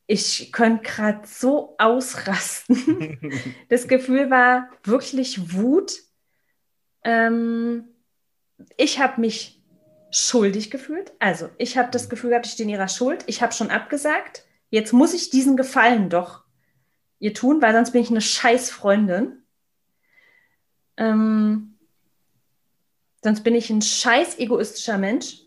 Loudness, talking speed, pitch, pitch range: -20 LUFS, 125 wpm, 235 Hz, 215-260 Hz